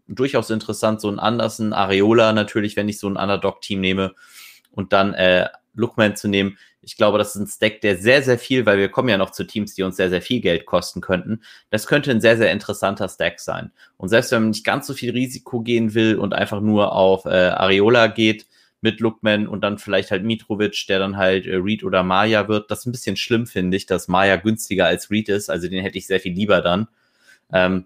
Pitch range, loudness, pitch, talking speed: 95-110 Hz, -19 LUFS, 105 Hz, 230 wpm